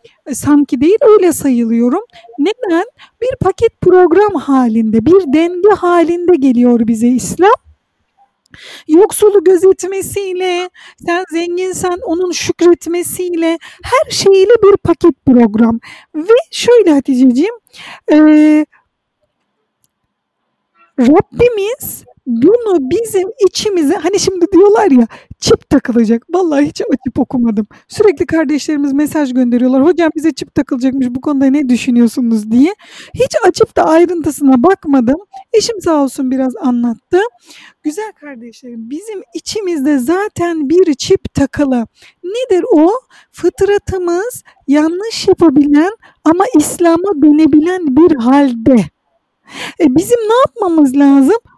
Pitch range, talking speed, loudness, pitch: 280-380 Hz, 105 wpm, -11 LUFS, 335 Hz